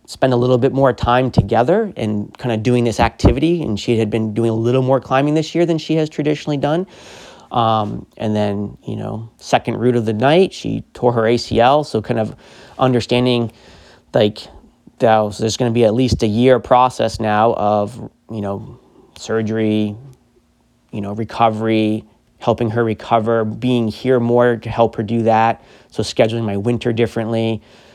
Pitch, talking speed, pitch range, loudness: 115 Hz, 175 wpm, 110-125 Hz, -17 LUFS